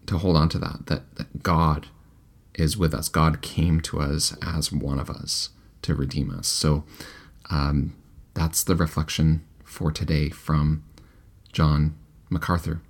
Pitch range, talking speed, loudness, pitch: 75-80 Hz, 150 wpm, -25 LUFS, 80 Hz